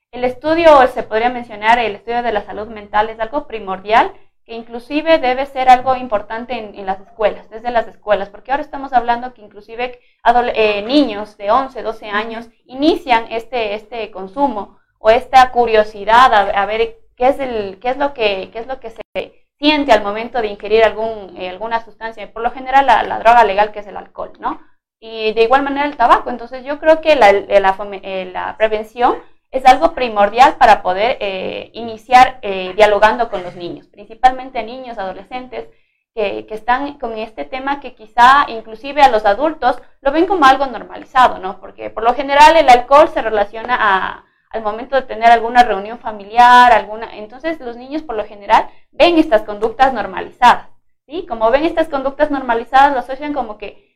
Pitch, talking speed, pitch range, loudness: 235 Hz, 185 wpm, 215-260 Hz, -14 LUFS